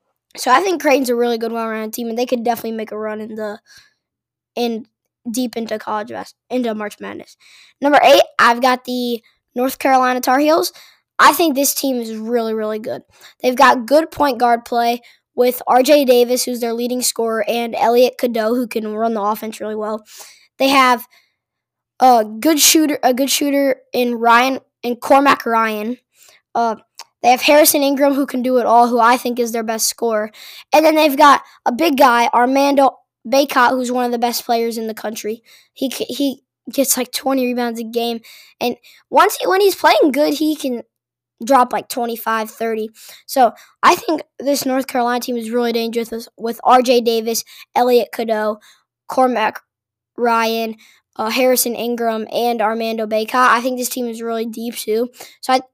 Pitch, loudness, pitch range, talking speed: 245 Hz, -16 LUFS, 230-265 Hz, 180 wpm